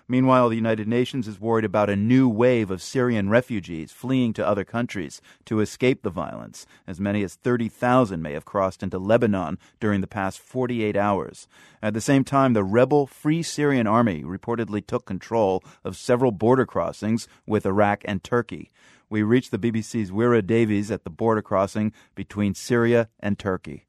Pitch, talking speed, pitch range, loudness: 110 Hz, 175 wpm, 100-120 Hz, -23 LUFS